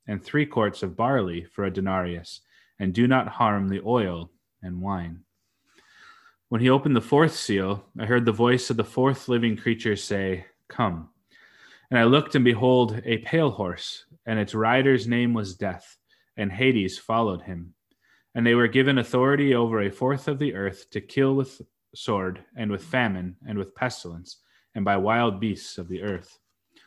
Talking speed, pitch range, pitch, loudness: 175 wpm, 95-130 Hz, 115 Hz, -24 LUFS